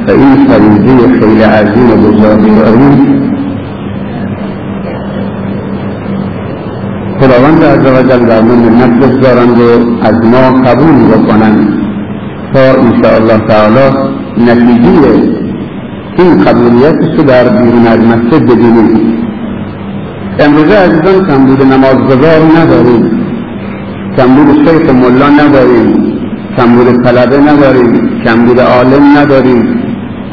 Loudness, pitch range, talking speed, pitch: -5 LUFS, 115-135 Hz, 100 wpm, 125 Hz